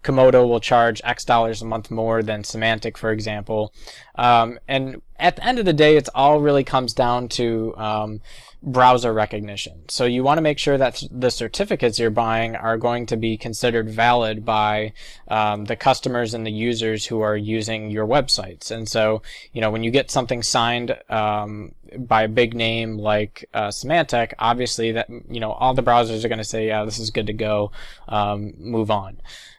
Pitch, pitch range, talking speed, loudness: 115 Hz, 110-125 Hz, 195 wpm, -20 LUFS